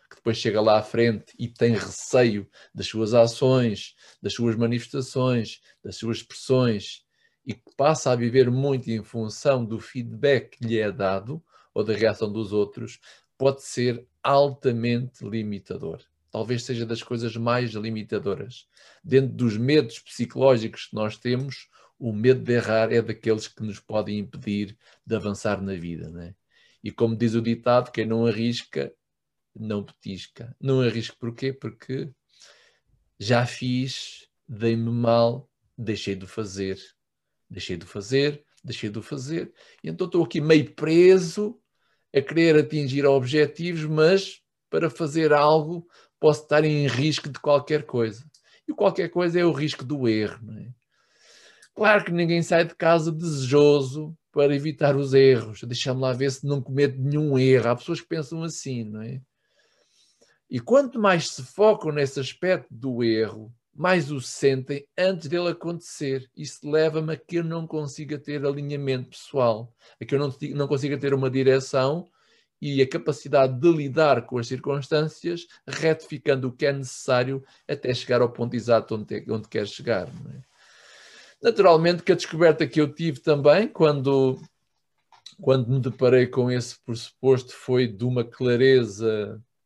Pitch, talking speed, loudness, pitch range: 130 Hz, 155 wpm, -24 LUFS, 115-150 Hz